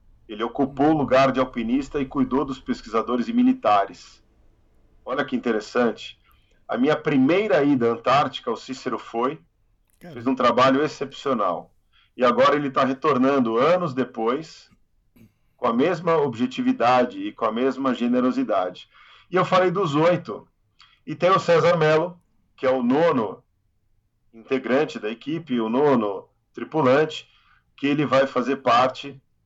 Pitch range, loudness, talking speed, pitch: 120-155 Hz, -22 LUFS, 140 wpm, 135 Hz